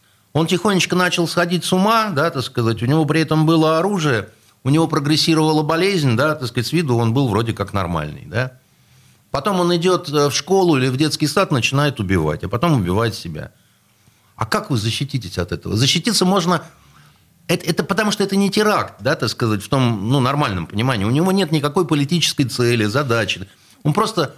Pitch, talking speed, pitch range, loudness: 145 Hz, 190 wpm, 115-170 Hz, -18 LUFS